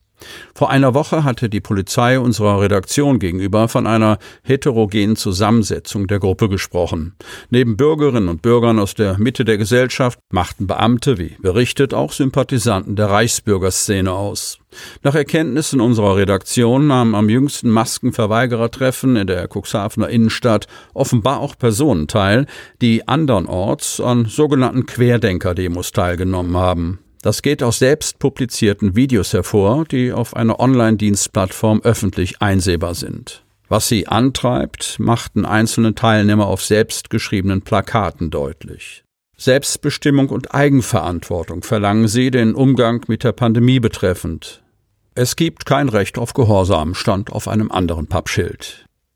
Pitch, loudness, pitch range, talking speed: 115 Hz, -16 LUFS, 100-125 Hz, 125 wpm